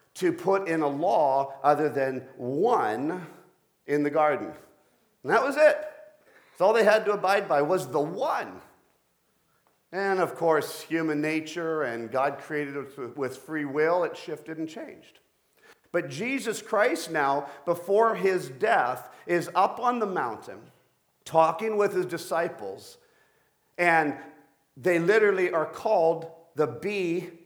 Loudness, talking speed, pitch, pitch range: -26 LUFS, 140 wpm, 165 Hz, 150-200 Hz